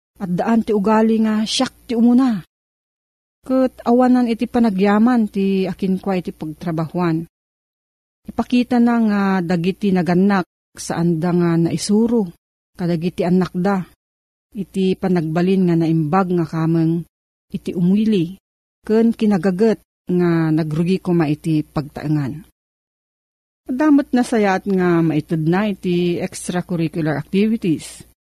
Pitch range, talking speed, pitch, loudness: 170-215 Hz, 110 wpm, 190 Hz, -18 LUFS